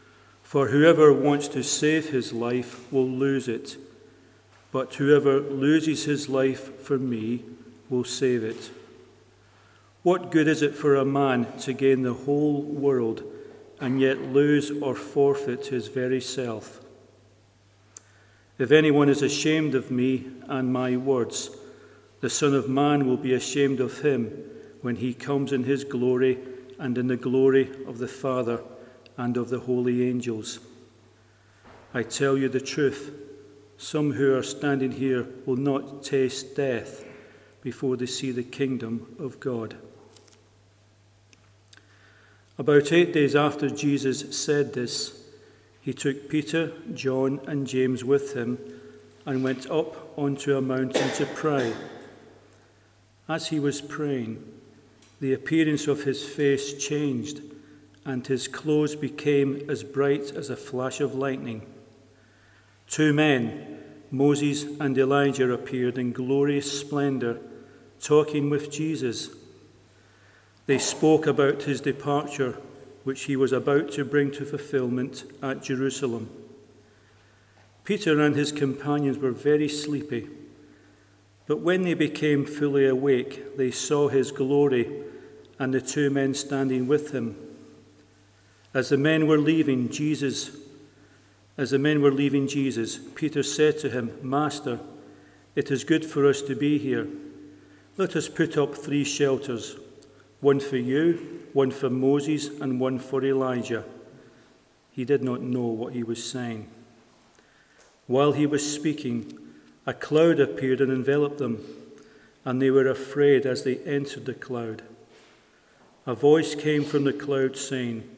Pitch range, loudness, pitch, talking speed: 120-145 Hz, -25 LUFS, 135 Hz, 135 wpm